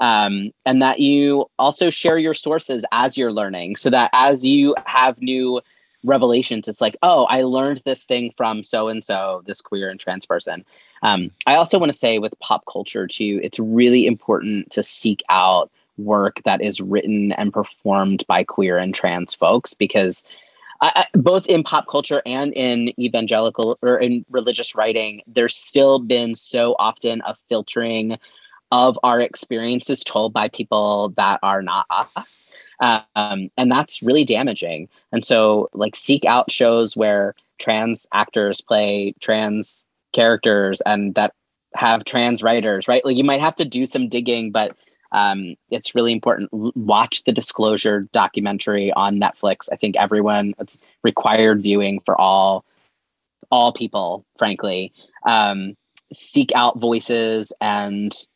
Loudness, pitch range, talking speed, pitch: -18 LUFS, 105-125 Hz, 155 wpm, 115 Hz